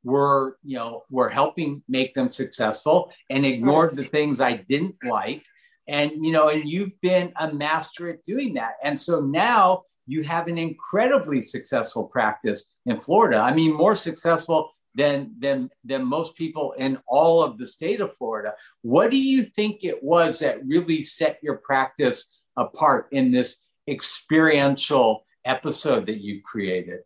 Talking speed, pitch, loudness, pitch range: 160 wpm, 160 Hz, -22 LUFS, 140-185 Hz